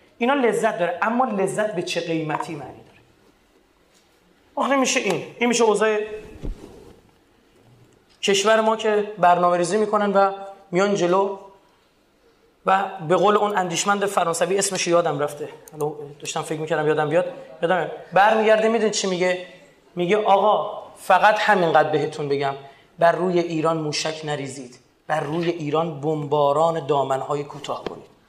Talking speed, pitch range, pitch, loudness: 130 wpm, 155-210 Hz, 180 Hz, -21 LUFS